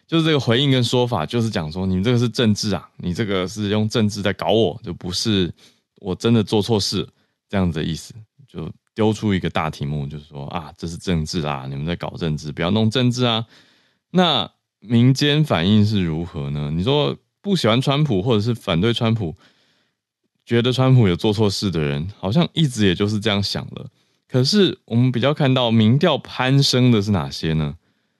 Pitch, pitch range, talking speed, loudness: 110 Hz, 90-125 Hz, 290 characters per minute, -19 LUFS